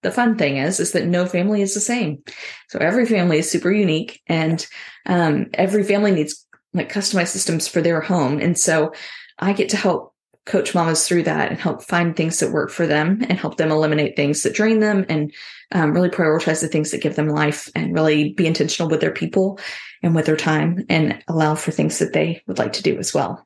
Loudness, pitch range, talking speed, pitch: -19 LUFS, 155-190 Hz, 225 wpm, 170 Hz